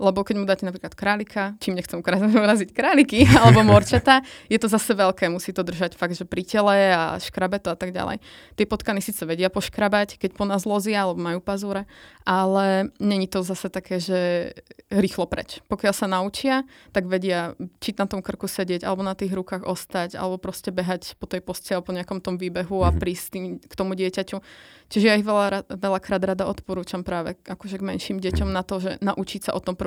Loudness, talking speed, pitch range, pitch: -23 LUFS, 205 wpm, 185-205 Hz, 195 Hz